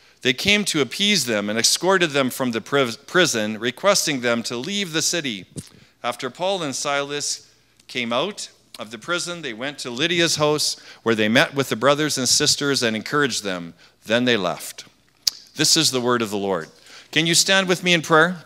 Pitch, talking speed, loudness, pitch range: 145 Hz, 190 wpm, -20 LUFS, 125-170 Hz